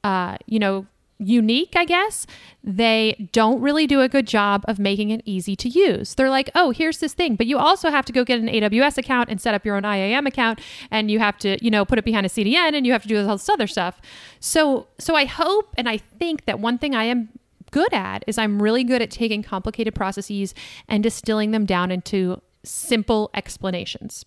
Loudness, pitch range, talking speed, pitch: -20 LUFS, 205-265 Hz, 225 wpm, 225 Hz